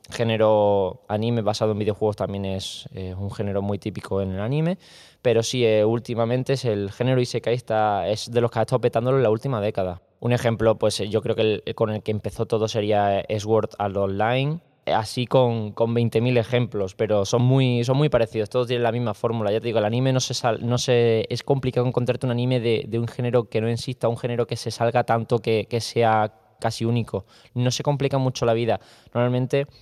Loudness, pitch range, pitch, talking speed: -23 LUFS, 110-125 Hz, 115 Hz, 215 wpm